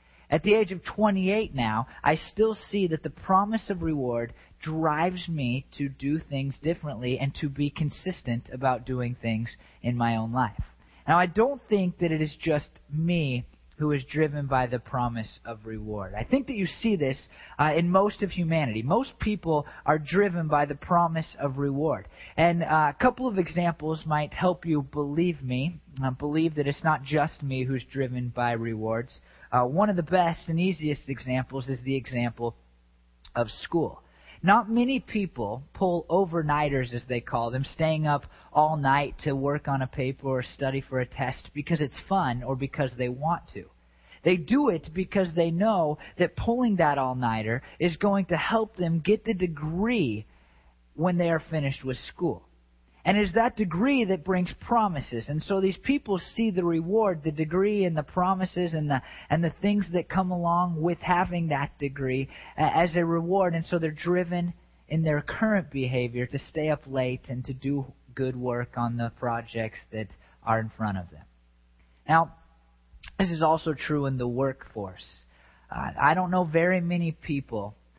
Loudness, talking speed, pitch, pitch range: -27 LUFS, 180 wpm, 150 Hz, 125-175 Hz